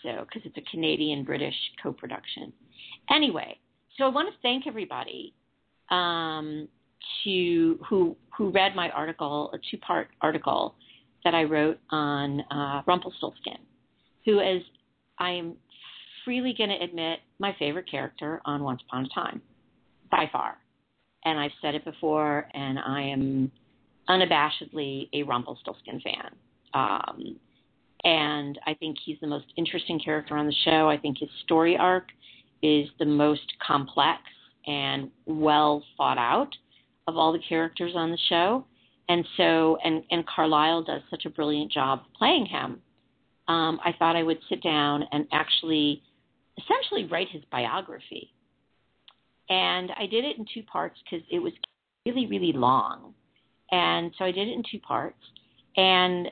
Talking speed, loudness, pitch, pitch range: 145 wpm, -27 LUFS, 160 Hz, 150-180 Hz